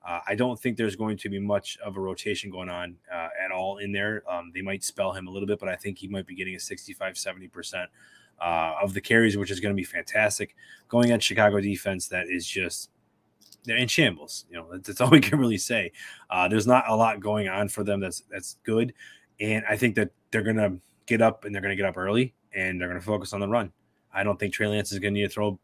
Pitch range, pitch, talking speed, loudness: 95-110 Hz, 100 Hz, 260 wpm, -26 LUFS